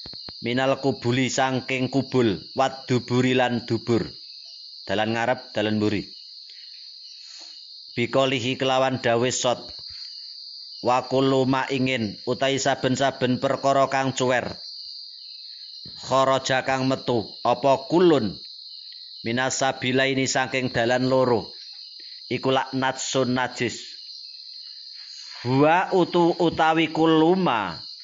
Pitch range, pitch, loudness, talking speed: 125-135 Hz, 130 Hz, -23 LUFS, 85 wpm